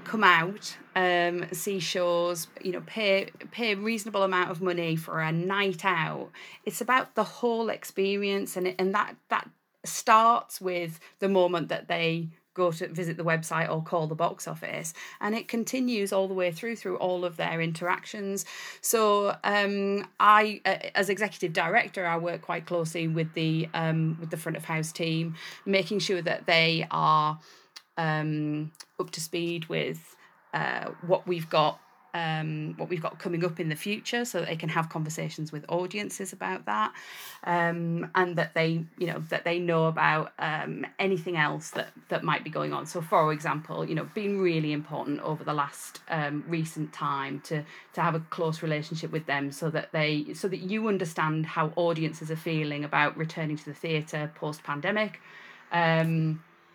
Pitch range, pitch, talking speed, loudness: 160-190 Hz, 170 Hz, 180 wpm, -28 LUFS